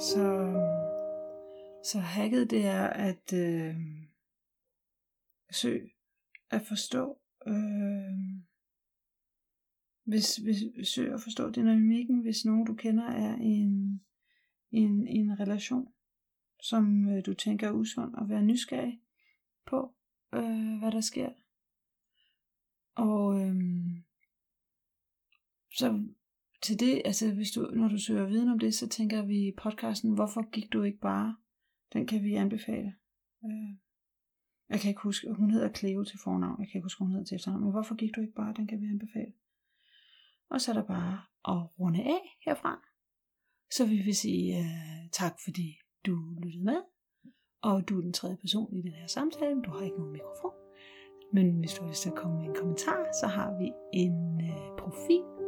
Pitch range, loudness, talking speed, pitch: 195-230 Hz, -32 LUFS, 155 wpm, 210 Hz